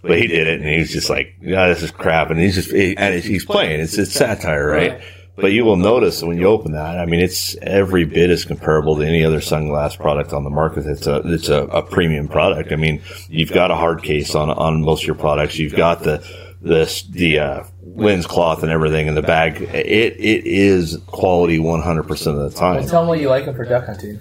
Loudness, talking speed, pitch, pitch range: -17 LUFS, 245 wpm, 85 Hz, 75-95 Hz